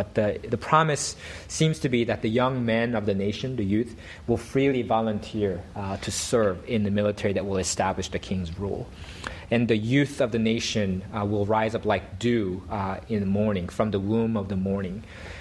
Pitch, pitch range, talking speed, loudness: 105 Hz, 95-115 Hz, 205 wpm, -26 LUFS